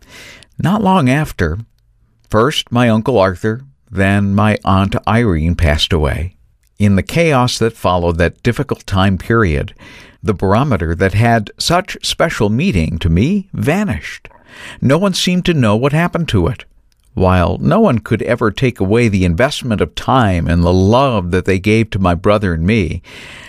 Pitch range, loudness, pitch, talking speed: 90-120 Hz, -14 LUFS, 105 Hz, 160 wpm